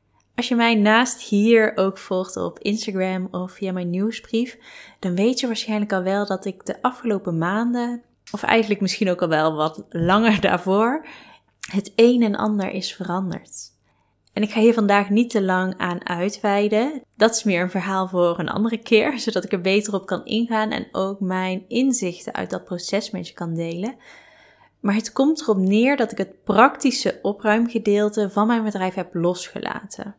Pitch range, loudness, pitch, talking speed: 185-230 Hz, -21 LUFS, 205 Hz, 180 wpm